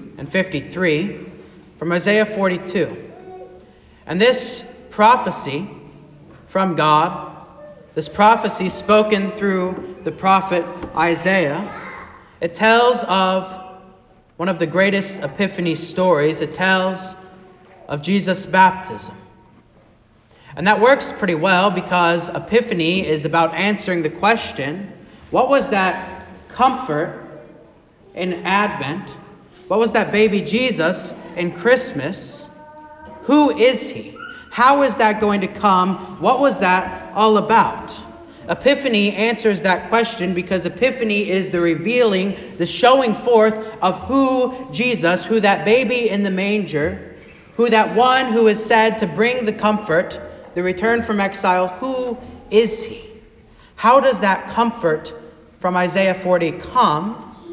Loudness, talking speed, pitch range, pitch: -17 LUFS, 120 wpm, 180-230 Hz, 195 Hz